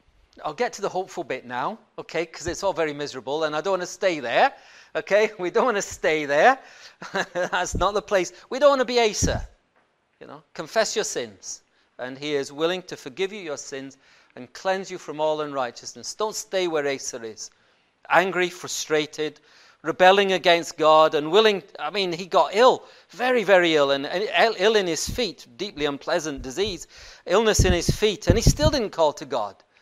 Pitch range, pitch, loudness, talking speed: 150-200 Hz, 175 Hz, -23 LUFS, 195 wpm